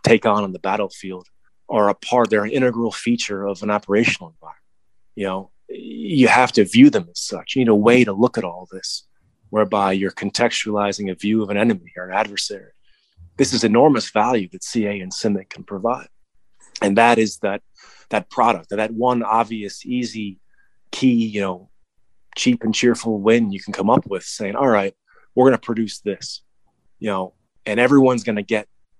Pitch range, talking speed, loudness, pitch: 100-120 Hz, 190 wpm, -19 LUFS, 105 Hz